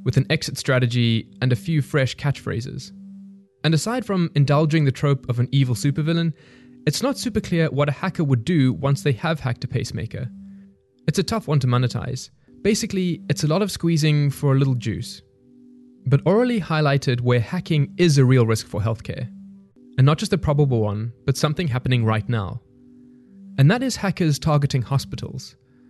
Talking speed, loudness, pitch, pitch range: 180 wpm, -21 LUFS, 140 Hz, 125-170 Hz